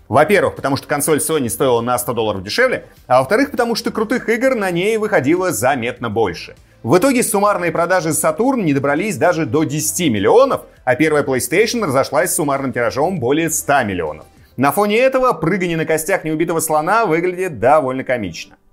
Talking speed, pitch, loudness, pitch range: 170 wpm, 160 Hz, -16 LUFS, 135-205 Hz